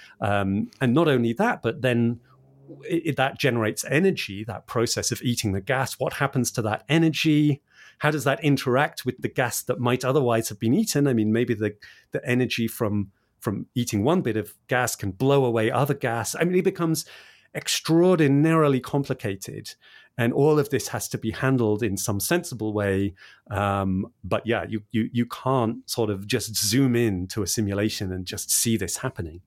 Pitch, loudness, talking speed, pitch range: 120 Hz, -24 LUFS, 185 wpm, 110-135 Hz